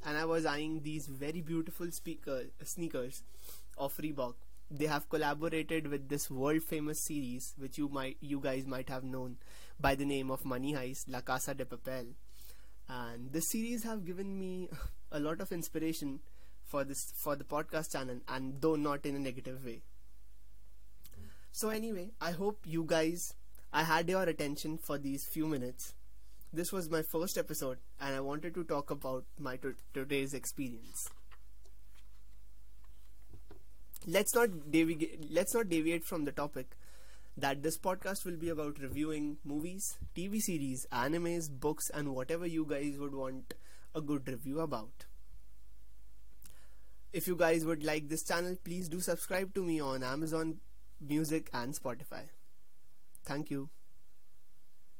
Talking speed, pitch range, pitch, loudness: 150 wpm, 130-165 Hz, 145 Hz, -38 LUFS